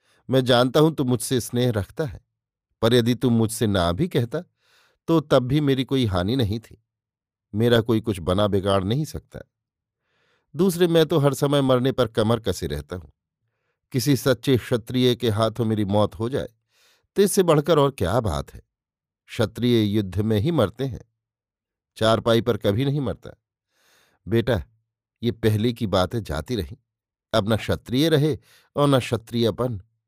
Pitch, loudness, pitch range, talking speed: 115 Hz, -22 LUFS, 105-130 Hz, 165 wpm